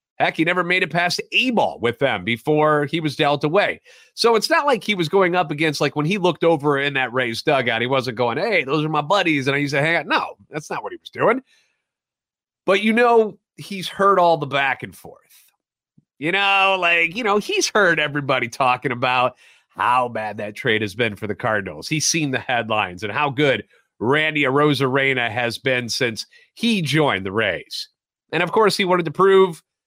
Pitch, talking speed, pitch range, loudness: 150 Hz, 215 wpm, 130-190 Hz, -19 LUFS